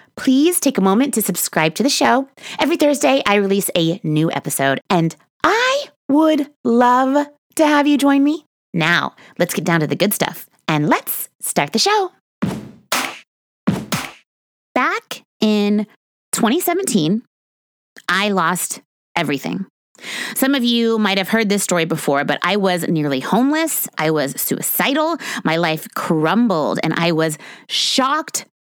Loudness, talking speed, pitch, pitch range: -17 LUFS, 145 wpm, 225 Hz, 170-285 Hz